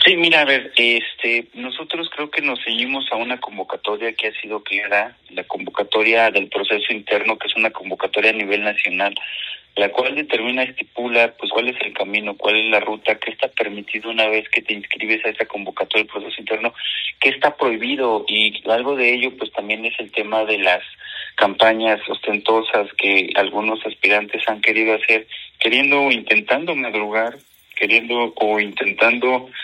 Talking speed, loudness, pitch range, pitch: 170 wpm, -18 LUFS, 105-120 Hz, 110 Hz